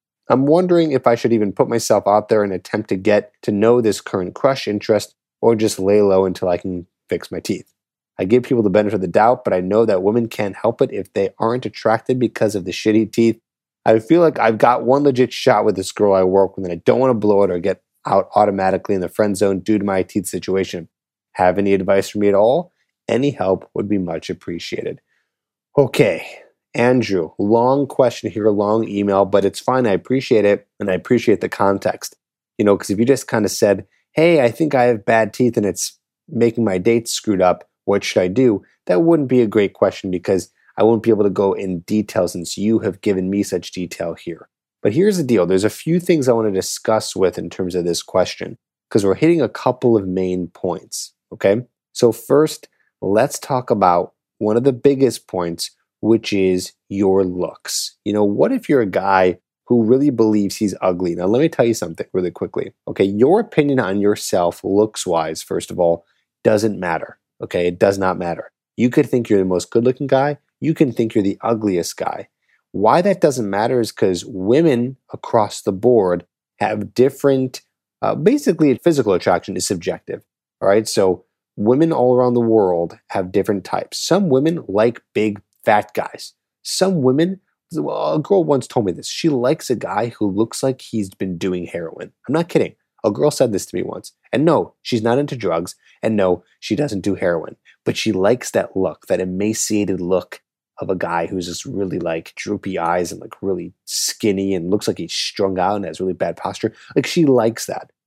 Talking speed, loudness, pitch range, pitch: 210 wpm, -18 LUFS, 95-125 Hz, 105 Hz